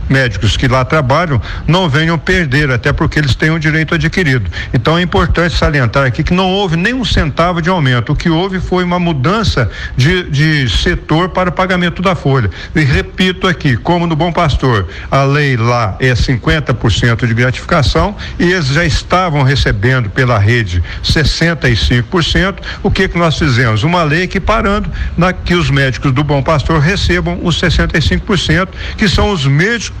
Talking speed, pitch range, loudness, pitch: 170 wpm, 130-175 Hz, -12 LUFS, 150 Hz